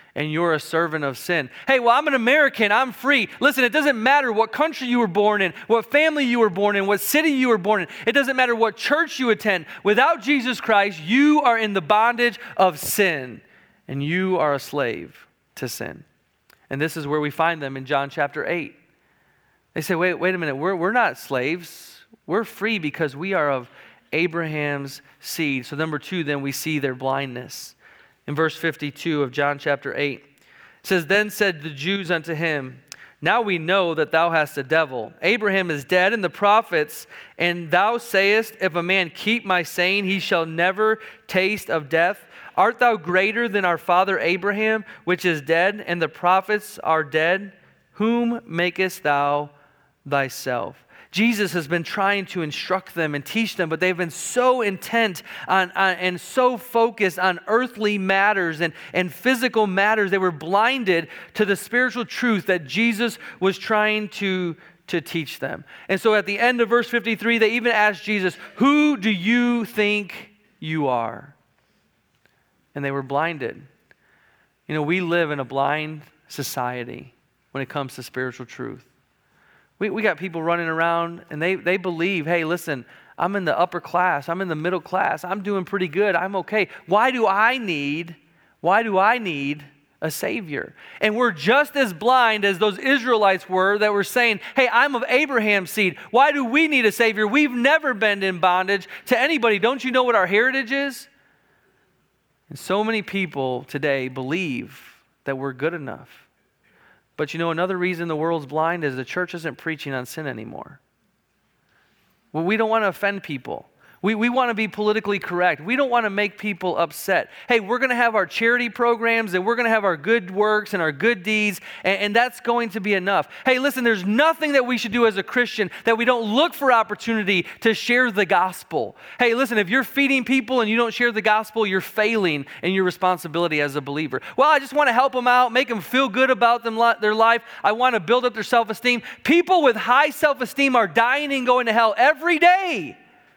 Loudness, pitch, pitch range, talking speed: -21 LUFS, 195 Hz, 165-235 Hz, 195 wpm